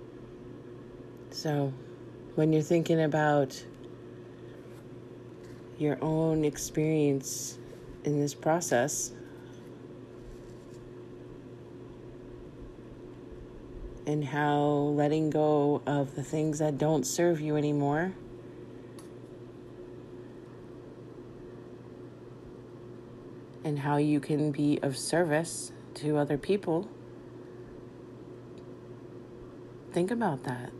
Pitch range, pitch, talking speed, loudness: 125-155 Hz, 145 Hz, 70 wpm, -29 LUFS